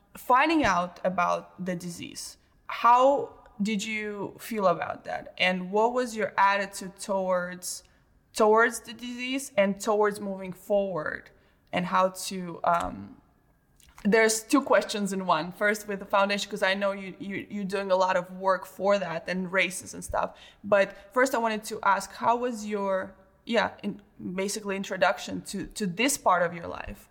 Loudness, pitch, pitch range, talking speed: -27 LUFS, 200 Hz, 185-215 Hz, 165 wpm